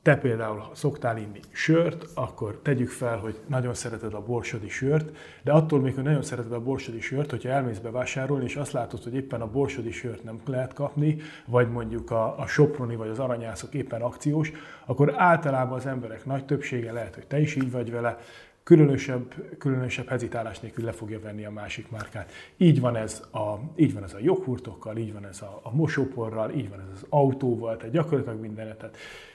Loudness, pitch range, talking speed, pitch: -27 LUFS, 115-140 Hz, 190 wpm, 125 Hz